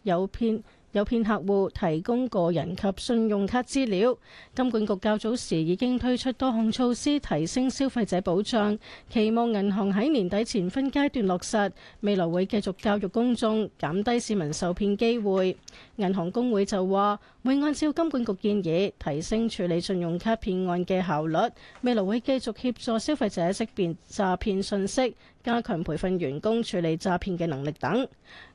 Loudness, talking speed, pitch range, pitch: -27 LUFS, 260 characters per minute, 185-235 Hz, 205 Hz